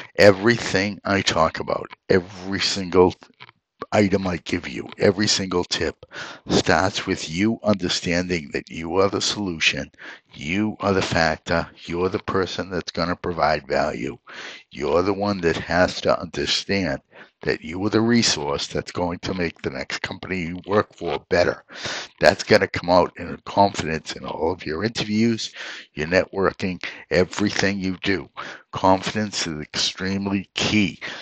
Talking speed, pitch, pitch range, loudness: 150 wpm, 95 Hz, 90-105 Hz, -22 LUFS